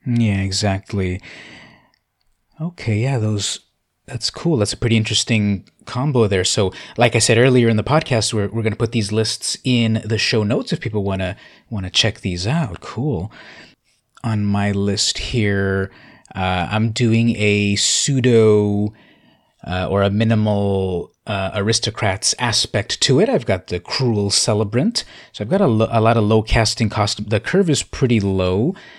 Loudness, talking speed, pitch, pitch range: -18 LUFS, 170 wpm, 110 Hz, 100-115 Hz